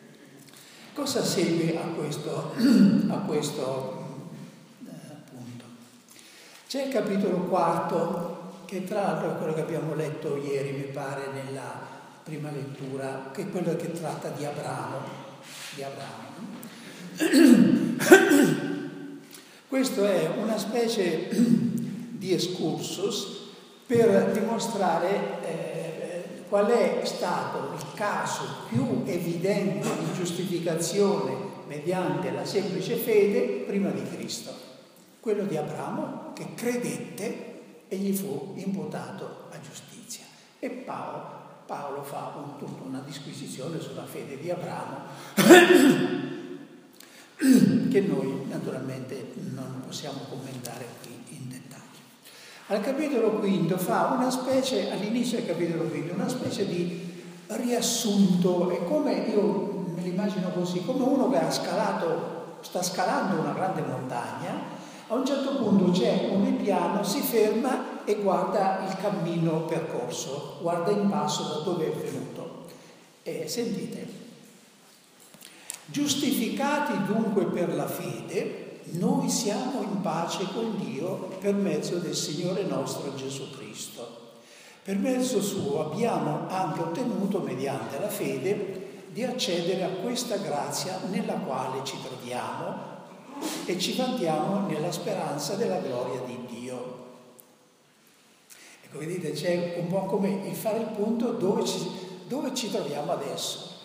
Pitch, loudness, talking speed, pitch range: 190 Hz, -27 LUFS, 120 wpm, 165-225 Hz